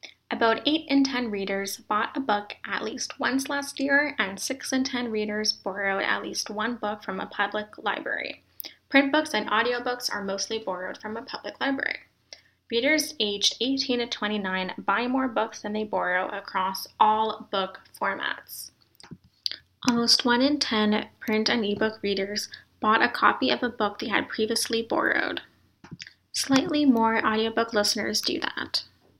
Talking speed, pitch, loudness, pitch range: 160 wpm, 220 Hz, -26 LUFS, 205-250 Hz